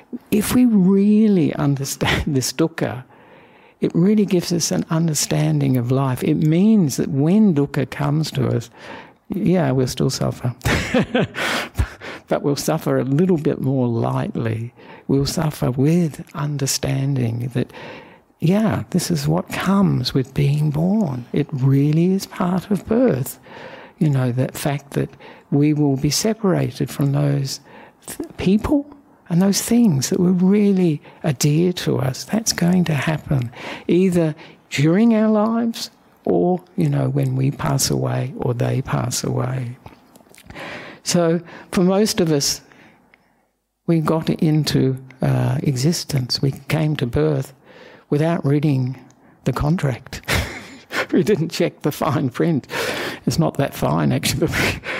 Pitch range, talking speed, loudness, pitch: 135-180 Hz, 135 wpm, -19 LUFS, 150 Hz